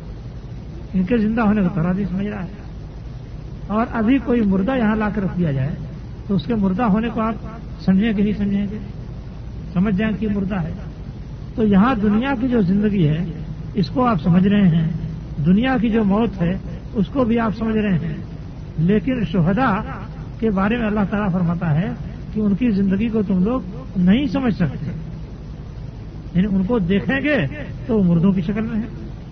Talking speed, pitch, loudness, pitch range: 185 wpm, 195 Hz, -19 LUFS, 170-220 Hz